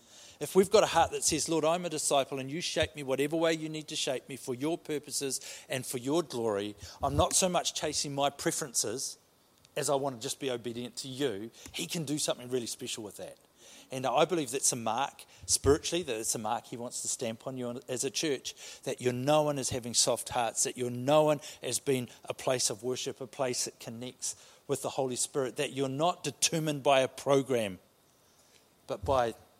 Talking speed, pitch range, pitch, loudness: 215 wpm, 125-155 Hz, 140 Hz, -31 LUFS